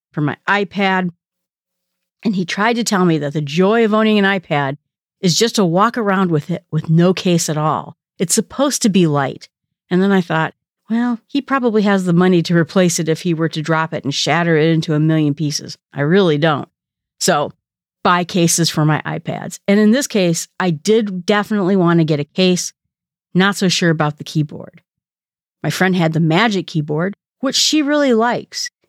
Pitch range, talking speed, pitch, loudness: 160-200 Hz, 200 wpm, 180 Hz, -16 LUFS